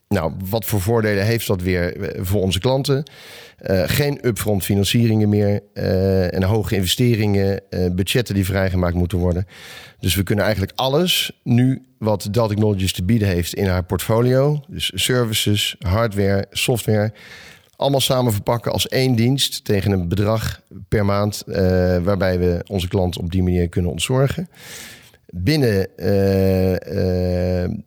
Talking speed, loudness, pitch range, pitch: 145 wpm, -19 LUFS, 95-115 Hz, 100 Hz